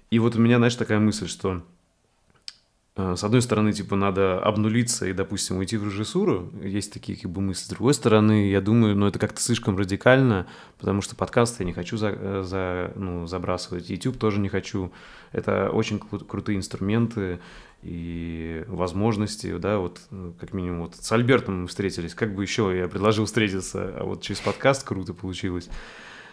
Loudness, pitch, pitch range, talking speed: -25 LUFS, 100 Hz, 95-110 Hz, 180 wpm